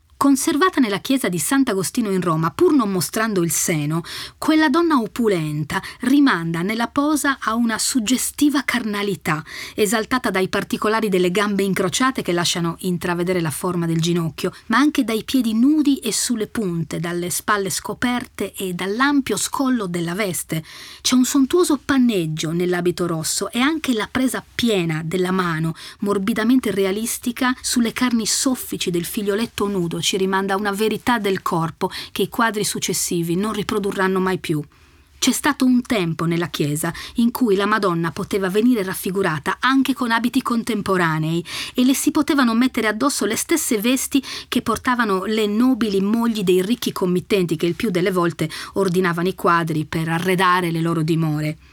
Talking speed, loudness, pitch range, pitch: 155 wpm, -20 LUFS, 180-245 Hz, 205 Hz